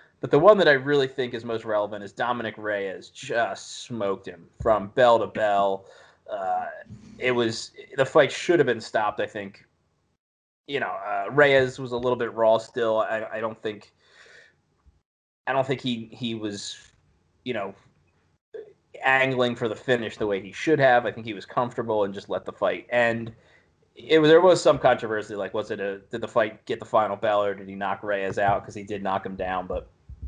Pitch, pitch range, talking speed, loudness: 115 Hz, 105-135 Hz, 200 wpm, -24 LUFS